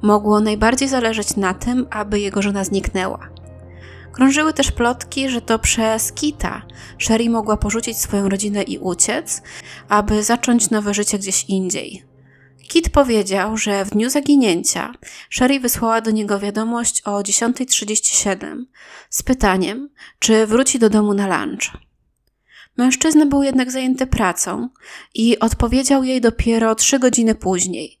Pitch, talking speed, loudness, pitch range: 220 Hz, 135 wpm, -17 LUFS, 200-250 Hz